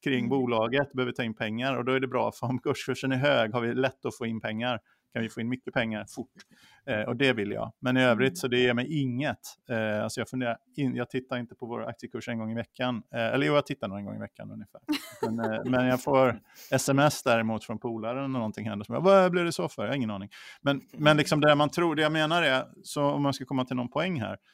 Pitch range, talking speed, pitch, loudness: 115-140 Hz, 265 wpm, 125 Hz, -28 LUFS